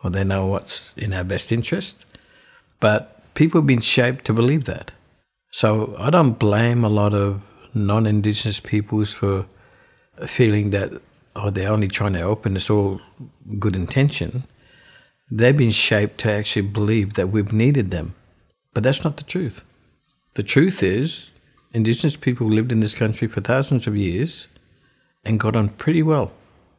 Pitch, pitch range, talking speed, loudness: 110 Hz, 100-125 Hz, 160 wpm, -20 LUFS